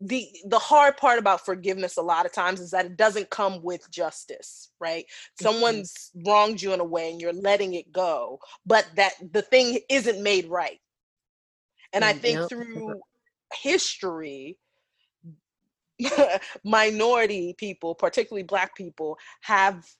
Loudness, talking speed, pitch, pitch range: -24 LUFS, 140 wpm, 200 Hz, 180-230 Hz